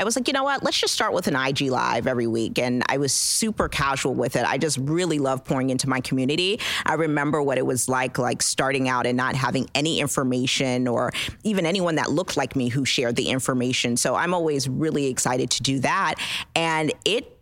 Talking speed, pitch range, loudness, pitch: 225 wpm, 130-160 Hz, -23 LUFS, 135 Hz